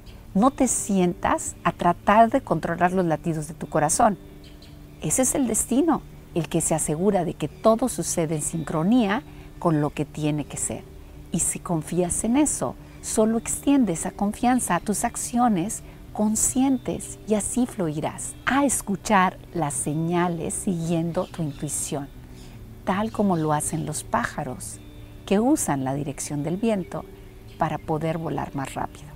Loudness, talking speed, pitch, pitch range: -24 LUFS, 150 wpm, 175 Hz, 150-215 Hz